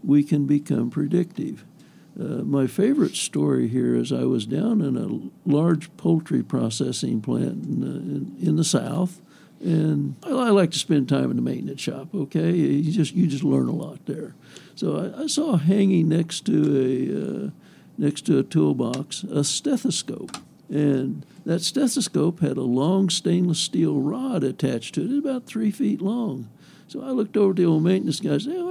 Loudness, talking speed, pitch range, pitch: -23 LUFS, 180 wpm, 145-200 Hz, 170 Hz